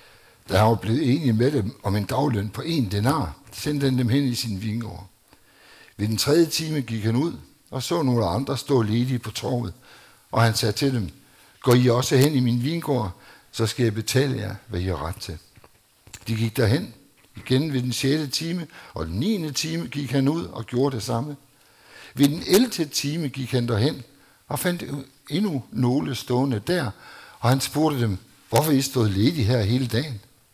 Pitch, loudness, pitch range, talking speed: 125 Hz, -23 LUFS, 115-140 Hz, 195 wpm